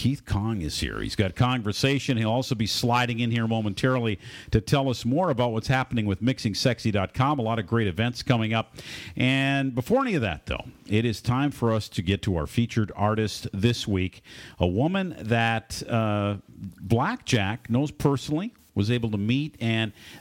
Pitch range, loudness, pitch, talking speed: 105-130 Hz, -26 LUFS, 115 Hz, 185 wpm